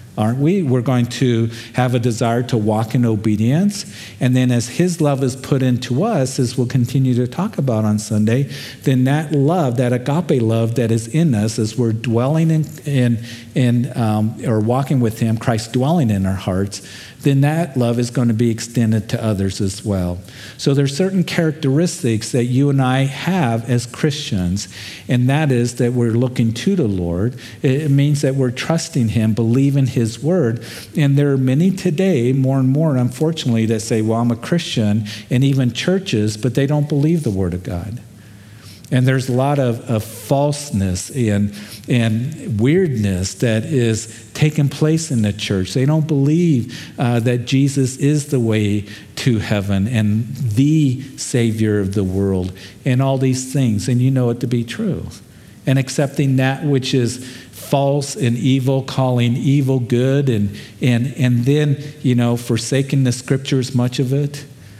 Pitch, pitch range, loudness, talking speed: 125 Hz, 115-140 Hz, -17 LUFS, 175 wpm